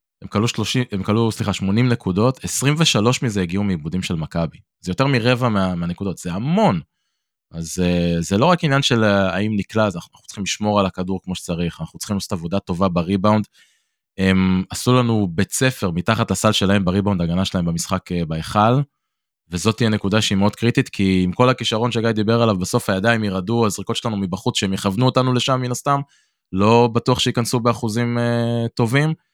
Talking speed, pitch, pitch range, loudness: 170 wpm, 105 Hz, 95-120 Hz, -19 LUFS